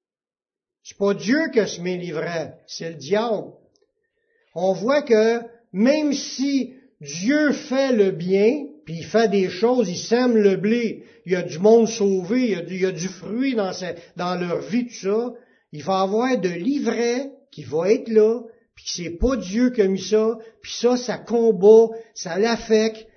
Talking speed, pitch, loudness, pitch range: 185 wpm, 220 Hz, -21 LUFS, 190-245 Hz